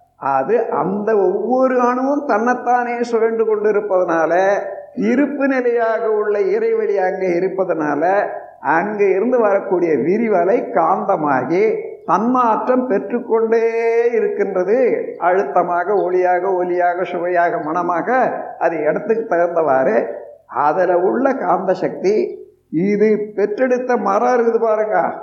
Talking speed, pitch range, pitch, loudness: 95 wpm, 180-255 Hz, 225 Hz, -17 LUFS